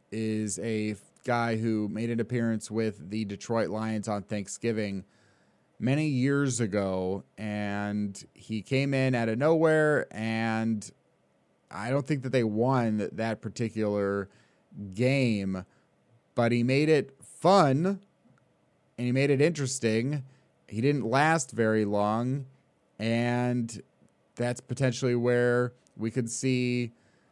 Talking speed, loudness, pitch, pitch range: 120 wpm, -28 LUFS, 115 Hz, 105-130 Hz